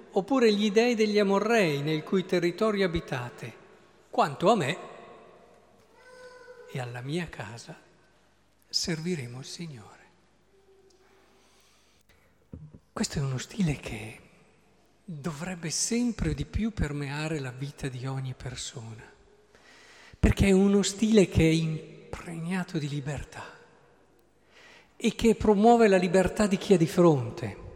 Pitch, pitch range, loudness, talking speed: 180 Hz, 150-220 Hz, -27 LUFS, 115 wpm